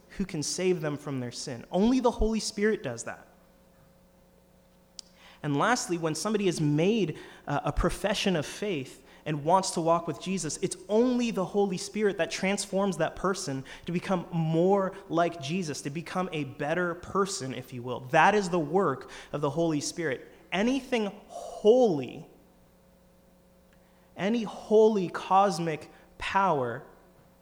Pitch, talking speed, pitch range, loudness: 180 Hz, 140 wpm, 155-200 Hz, -28 LUFS